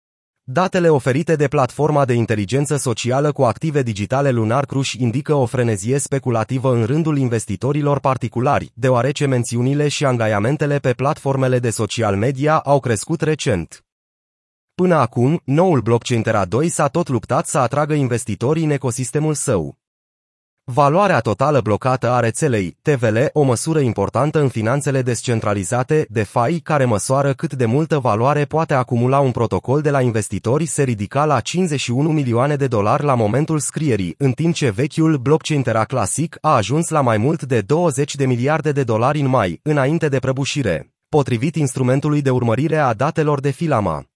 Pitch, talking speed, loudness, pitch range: 135 Hz, 155 wpm, -18 LUFS, 120-150 Hz